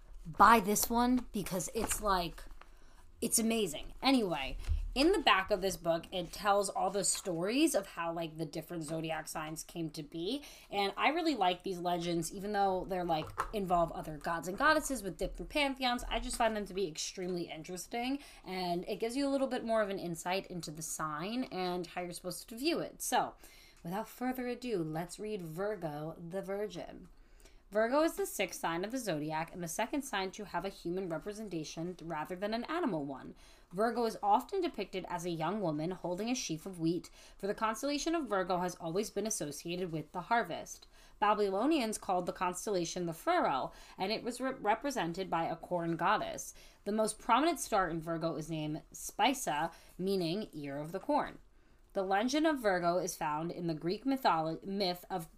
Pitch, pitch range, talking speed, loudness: 190 Hz, 170-225 Hz, 190 wpm, -35 LUFS